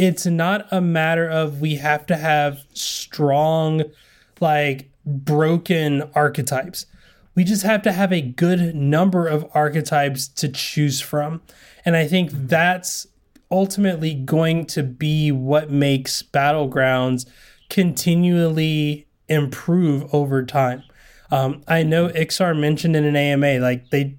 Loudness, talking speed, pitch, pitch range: -19 LUFS, 125 wpm, 150 Hz, 140-170 Hz